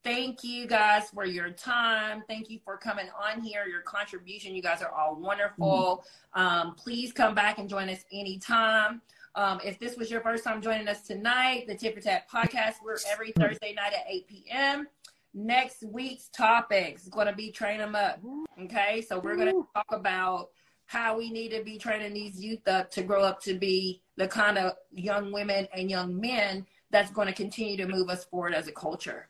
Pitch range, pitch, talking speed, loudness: 190-225 Hz, 205 Hz, 200 wpm, -29 LUFS